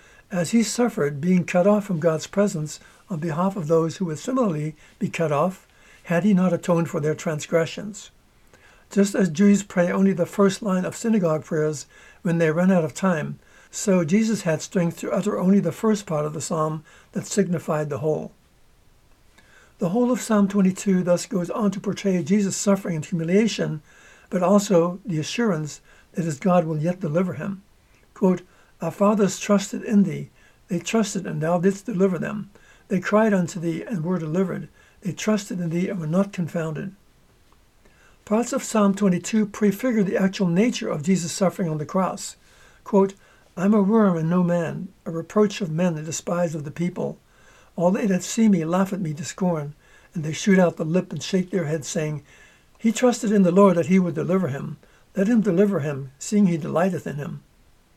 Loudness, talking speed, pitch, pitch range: -23 LUFS, 190 wpm, 185 Hz, 165-200 Hz